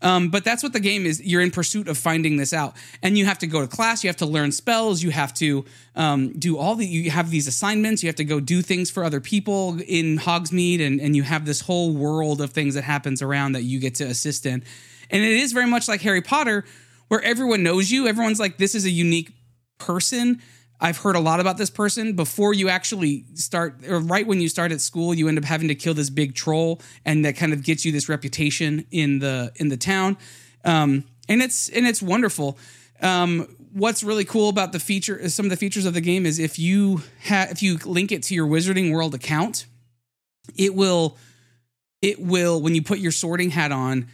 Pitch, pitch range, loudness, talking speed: 170 Hz, 145-195 Hz, -21 LUFS, 230 wpm